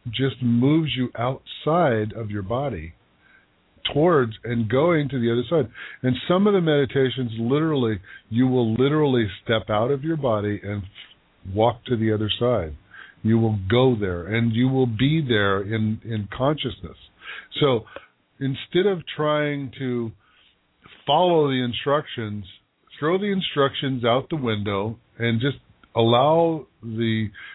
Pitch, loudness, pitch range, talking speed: 120 Hz, -23 LUFS, 110-140 Hz, 140 wpm